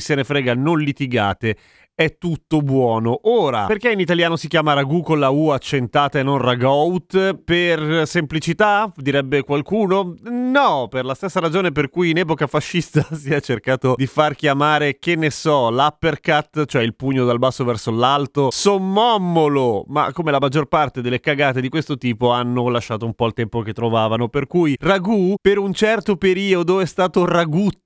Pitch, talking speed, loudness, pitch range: 150 Hz, 175 wpm, -18 LUFS, 130-175 Hz